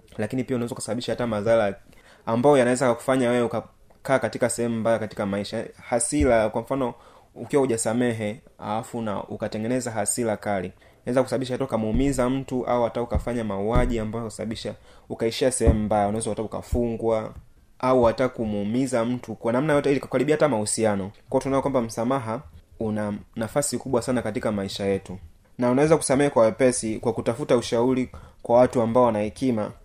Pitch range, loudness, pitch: 105-125 Hz, -24 LUFS, 115 Hz